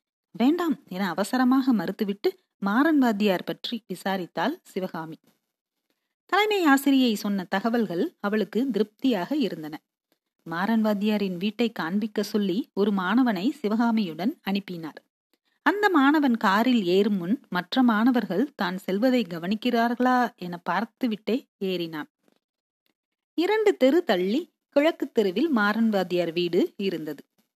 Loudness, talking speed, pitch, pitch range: -25 LUFS, 95 wpm, 220 Hz, 195-260 Hz